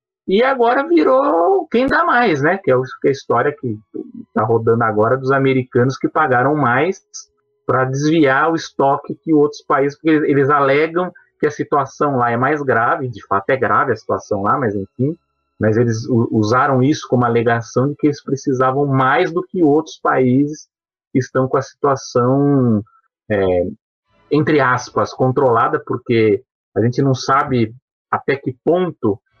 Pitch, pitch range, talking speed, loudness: 135 Hz, 120-155 Hz, 160 wpm, -16 LUFS